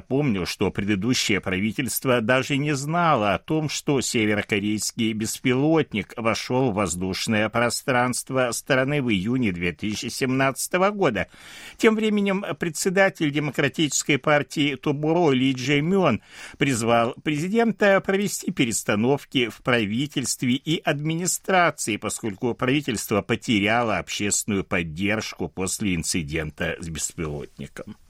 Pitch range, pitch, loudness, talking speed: 105-155 Hz, 130 Hz, -23 LUFS, 100 wpm